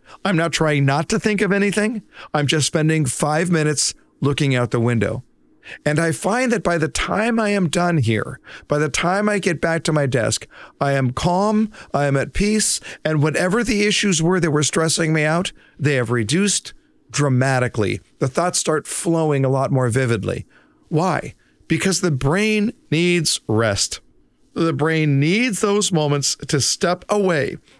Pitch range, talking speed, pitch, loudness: 135-185 Hz, 175 wpm, 160 Hz, -19 LUFS